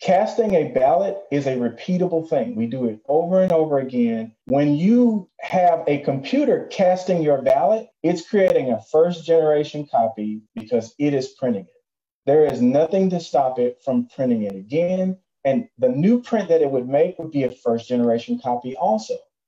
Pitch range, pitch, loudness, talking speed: 125-190 Hz, 160 Hz, -20 LUFS, 180 wpm